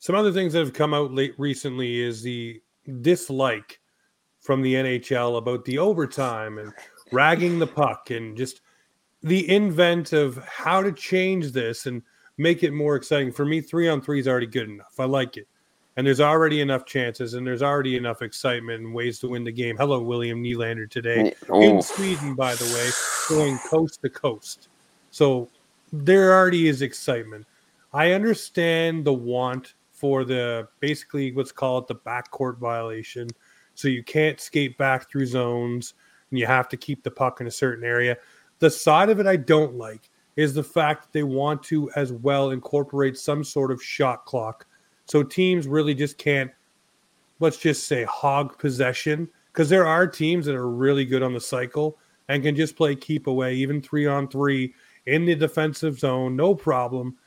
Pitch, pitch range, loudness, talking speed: 135 Hz, 125-155 Hz, -23 LUFS, 180 wpm